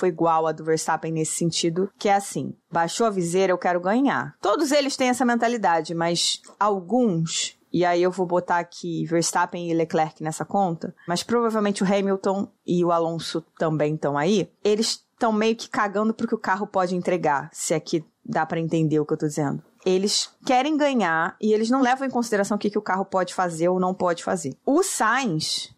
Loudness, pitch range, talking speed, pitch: -23 LUFS, 165-215 Hz, 205 wpm, 185 Hz